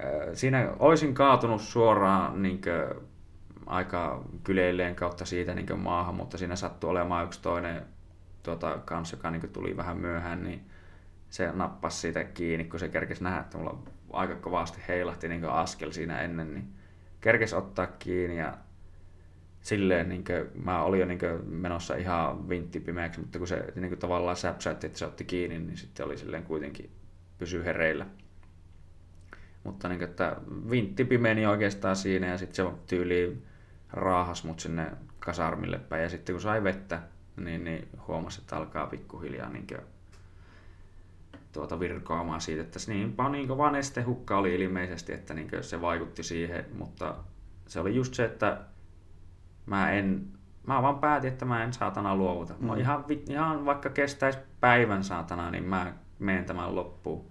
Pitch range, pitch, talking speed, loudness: 85-95 Hz, 90 Hz, 150 wpm, -31 LUFS